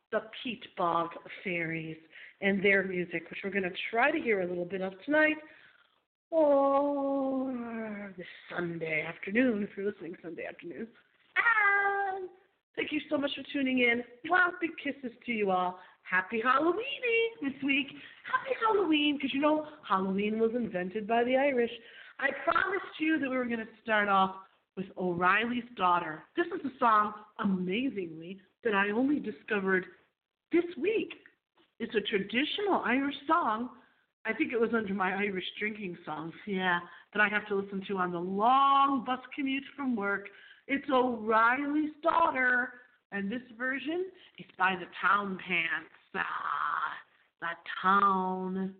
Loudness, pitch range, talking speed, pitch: -30 LUFS, 190-285 Hz, 150 wpm, 235 Hz